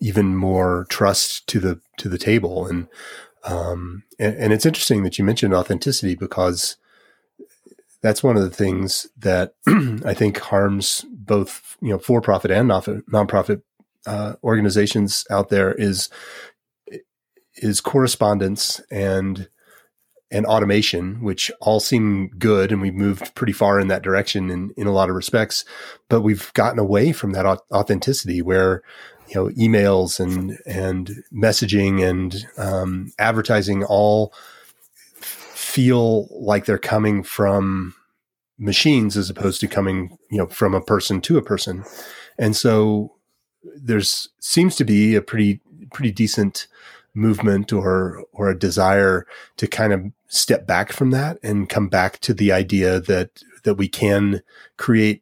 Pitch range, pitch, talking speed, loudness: 95-110 Hz, 100 Hz, 145 wpm, -19 LUFS